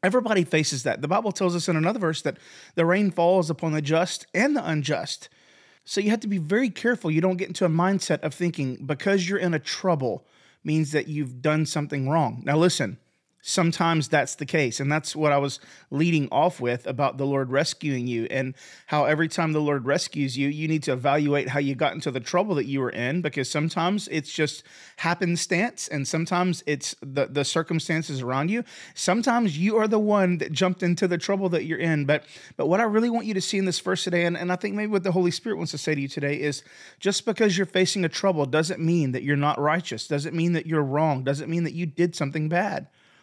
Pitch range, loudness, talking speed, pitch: 145-185 Hz, -25 LUFS, 230 wpm, 160 Hz